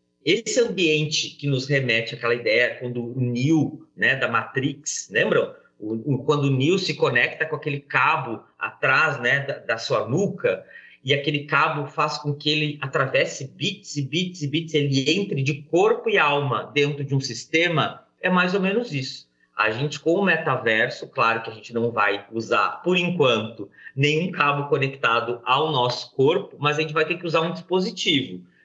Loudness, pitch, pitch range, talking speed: -22 LUFS, 150 Hz, 130-165 Hz, 180 wpm